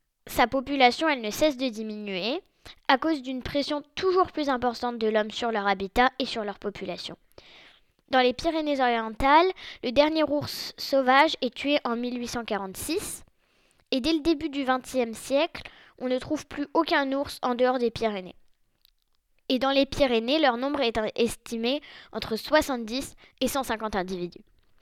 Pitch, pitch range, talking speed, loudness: 255 Hz, 230-290 Hz, 155 wpm, -26 LUFS